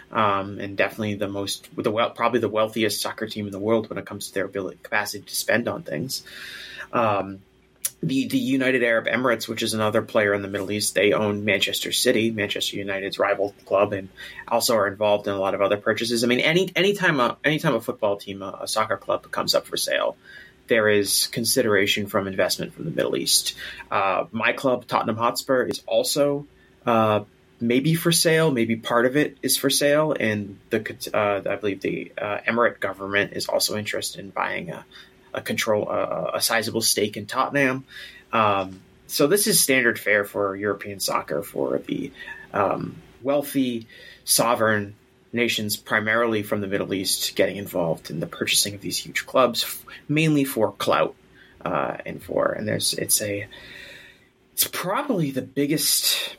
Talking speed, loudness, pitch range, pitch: 180 wpm, -23 LUFS, 100-130 Hz, 110 Hz